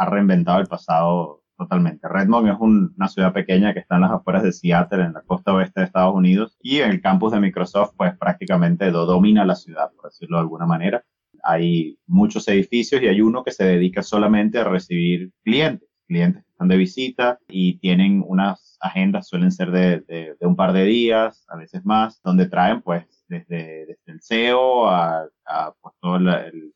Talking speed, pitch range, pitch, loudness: 200 wpm, 90-115 Hz, 95 Hz, -19 LUFS